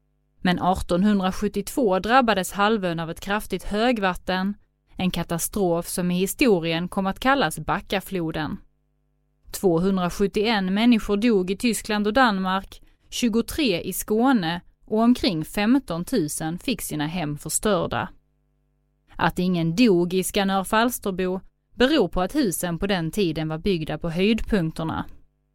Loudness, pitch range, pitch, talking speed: -23 LUFS, 175-215 Hz, 190 Hz, 120 wpm